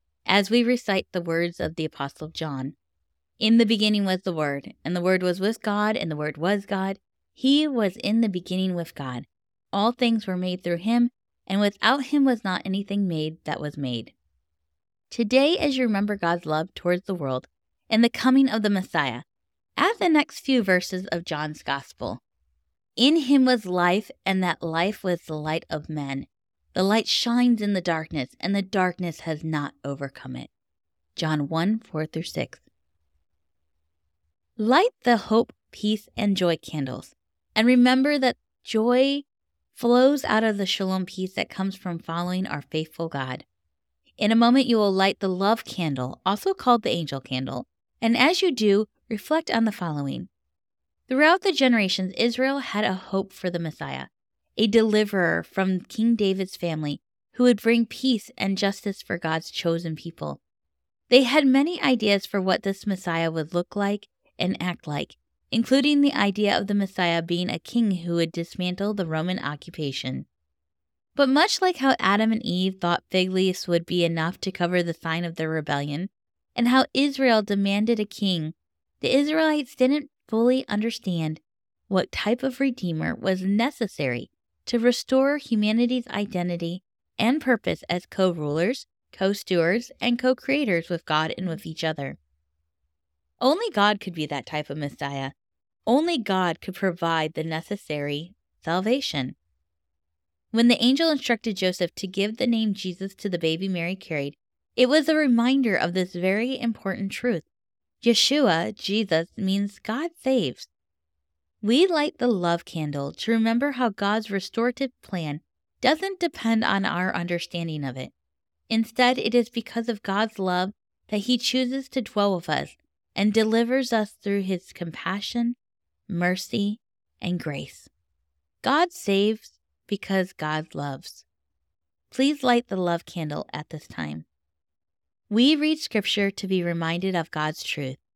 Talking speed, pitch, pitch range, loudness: 160 wpm, 190 Hz, 155-230 Hz, -24 LUFS